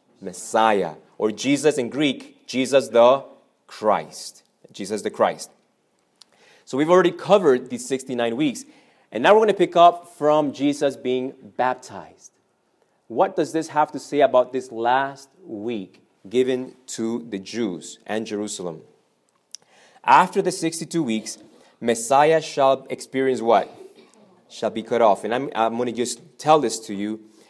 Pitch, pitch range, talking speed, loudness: 130 Hz, 115-165 Hz, 145 wpm, -21 LUFS